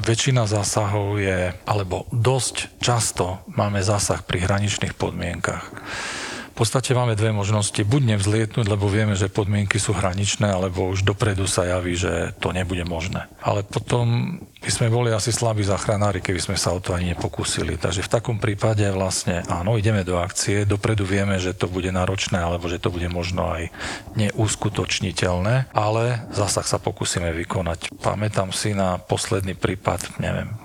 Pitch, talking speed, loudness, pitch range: 100 Hz, 160 wpm, -22 LUFS, 95-110 Hz